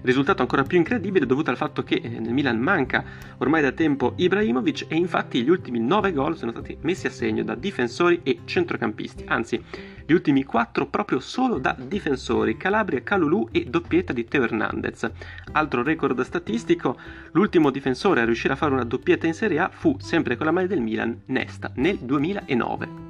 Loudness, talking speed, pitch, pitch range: -23 LUFS, 180 wpm, 160 Hz, 130-195 Hz